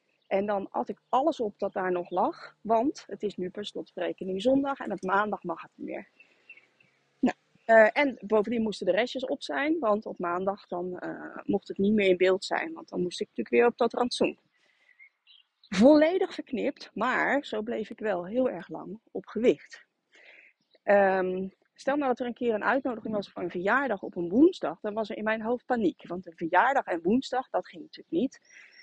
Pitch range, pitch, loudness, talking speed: 190-265 Hz, 215 Hz, -28 LUFS, 205 wpm